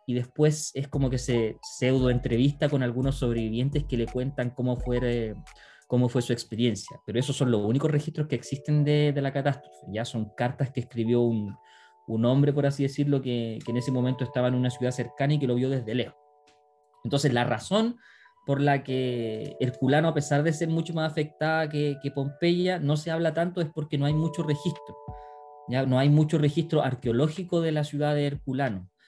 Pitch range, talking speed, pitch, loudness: 125-150 Hz, 200 wpm, 140 Hz, -27 LUFS